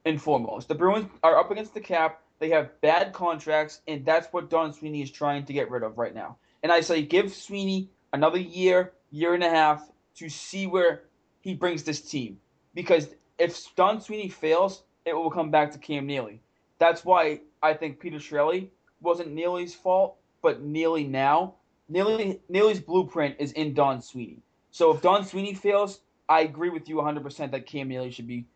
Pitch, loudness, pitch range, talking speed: 160 Hz, -26 LUFS, 150-185 Hz, 190 wpm